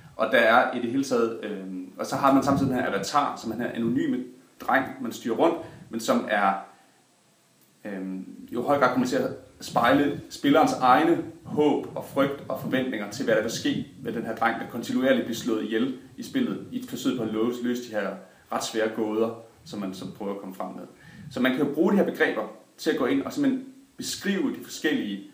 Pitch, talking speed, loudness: 120 Hz, 225 wpm, -26 LUFS